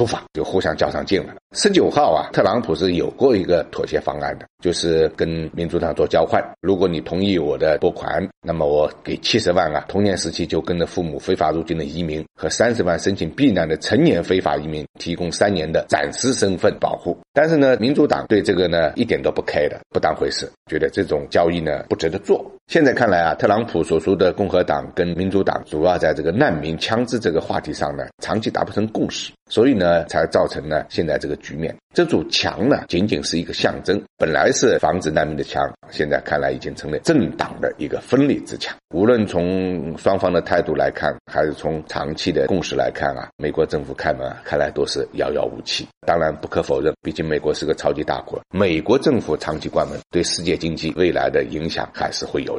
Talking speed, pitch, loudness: 330 characters per minute, 90 Hz, -20 LUFS